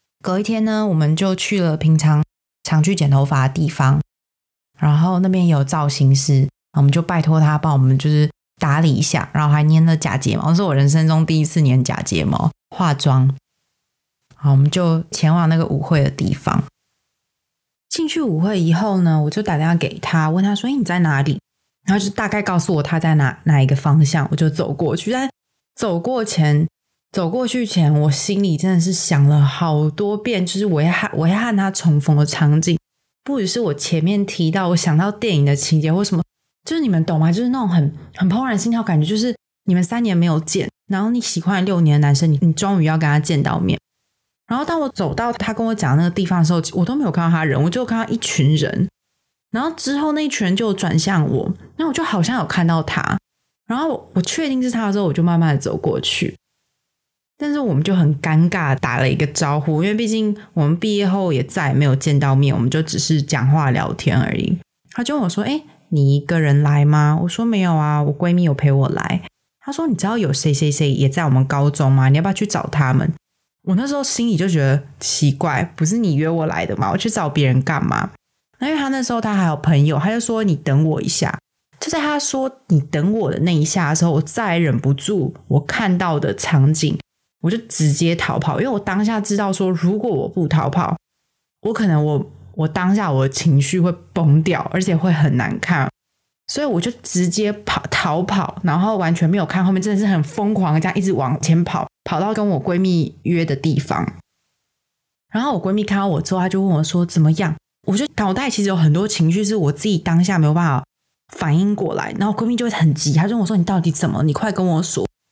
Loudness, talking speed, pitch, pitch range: -17 LUFS, 315 characters per minute, 170 Hz, 150-200 Hz